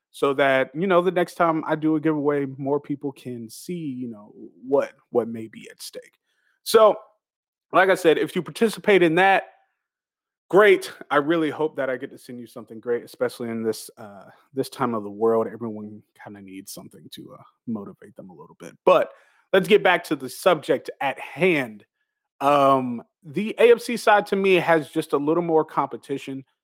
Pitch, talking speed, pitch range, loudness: 155 Hz, 195 wpm, 125-190 Hz, -22 LUFS